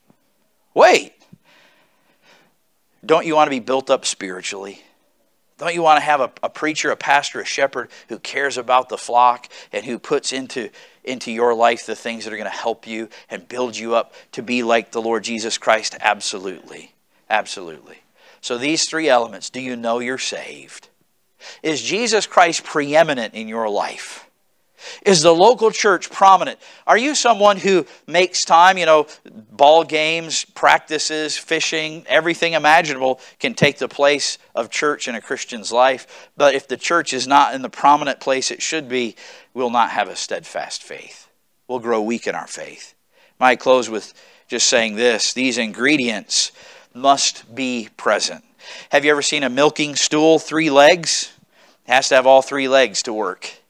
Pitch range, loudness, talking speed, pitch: 120-155 Hz, -17 LUFS, 170 wpm, 135 Hz